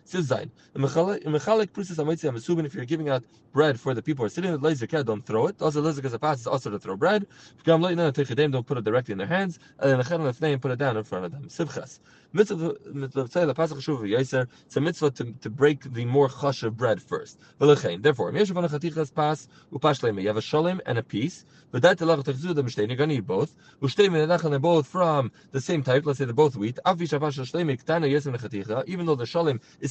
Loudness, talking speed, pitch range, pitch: -25 LUFS, 235 wpm, 130-165 Hz, 150 Hz